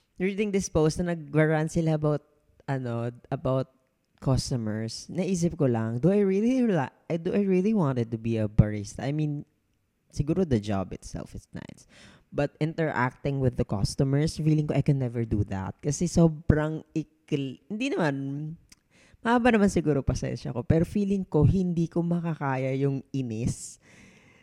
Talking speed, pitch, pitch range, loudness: 155 wpm, 150 Hz, 125-170 Hz, -27 LUFS